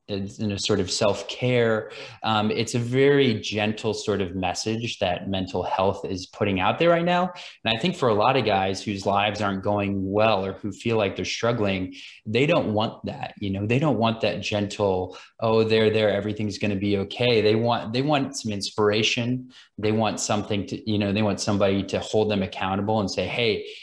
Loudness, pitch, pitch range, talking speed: -24 LUFS, 105 Hz, 100-115 Hz, 205 wpm